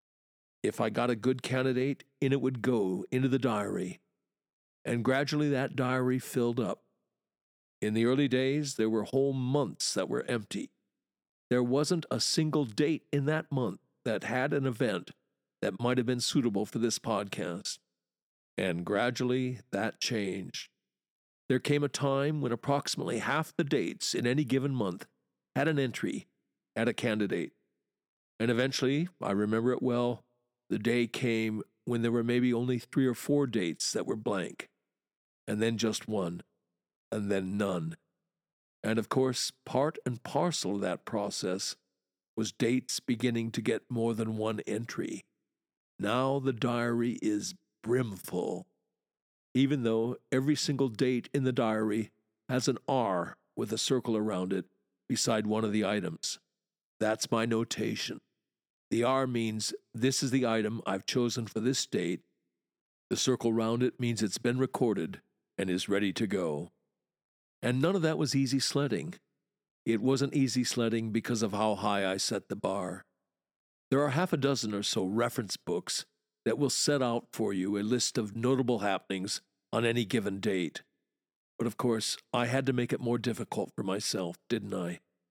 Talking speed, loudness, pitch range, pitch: 160 wpm, -31 LUFS, 110-130 Hz, 120 Hz